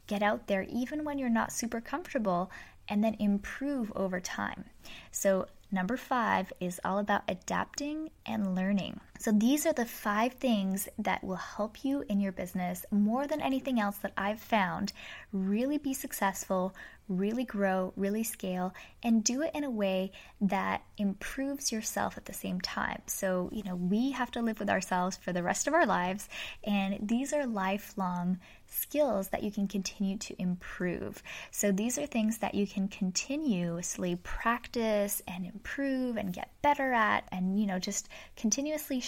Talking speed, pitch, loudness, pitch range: 165 wpm, 205 Hz, -32 LUFS, 190-250 Hz